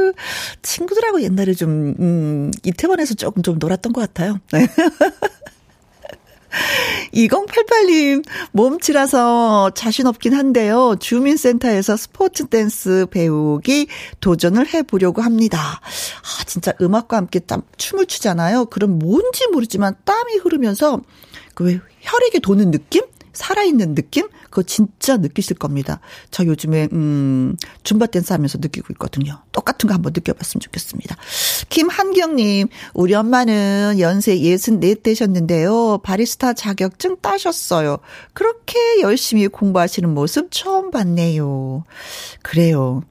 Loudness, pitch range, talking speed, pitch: -17 LUFS, 180-290 Hz, 285 characters per minute, 215 Hz